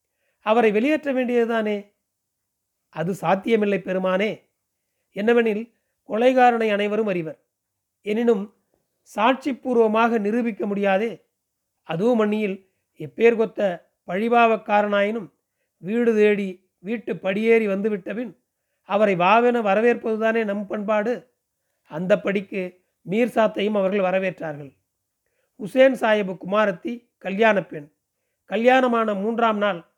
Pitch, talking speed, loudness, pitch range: 210 Hz, 85 wpm, -21 LUFS, 190-230 Hz